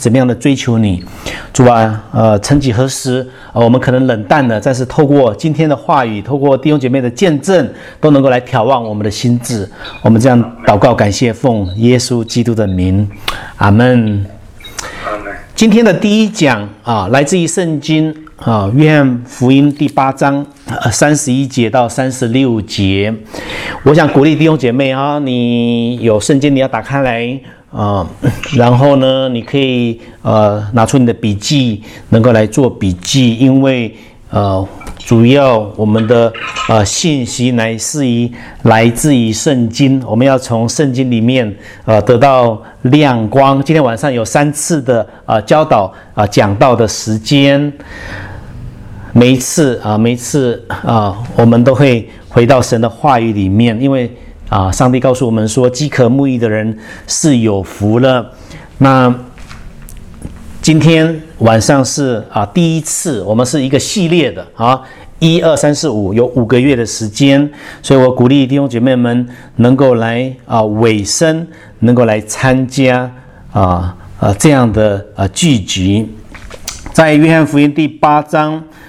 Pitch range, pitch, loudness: 110-140 Hz, 125 Hz, -11 LUFS